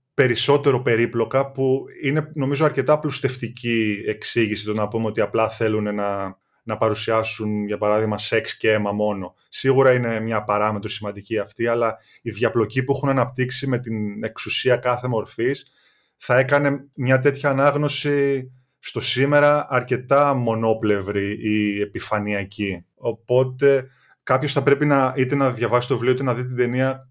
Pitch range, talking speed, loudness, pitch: 110-135 Hz, 145 wpm, -21 LUFS, 125 Hz